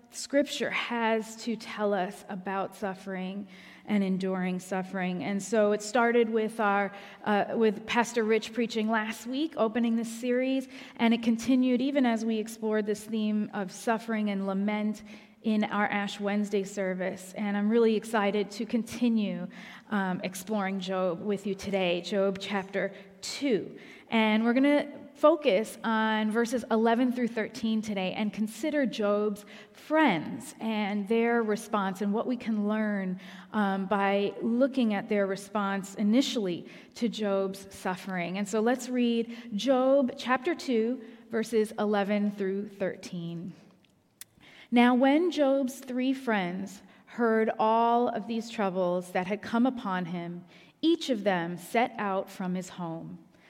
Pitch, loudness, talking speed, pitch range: 215 Hz, -29 LUFS, 140 wpm, 195-235 Hz